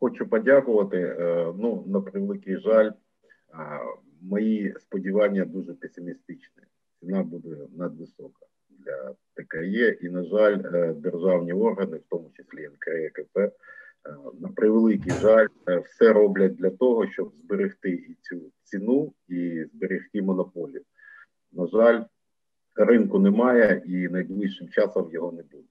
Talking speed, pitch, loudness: 110 wpm, 105 Hz, -24 LUFS